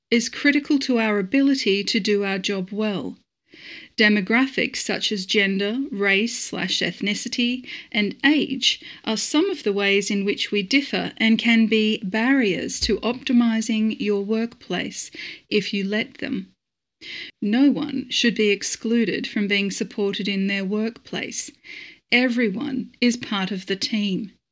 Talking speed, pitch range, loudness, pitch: 140 wpm, 205-260 Hz, -22 LUFS, 225 Hz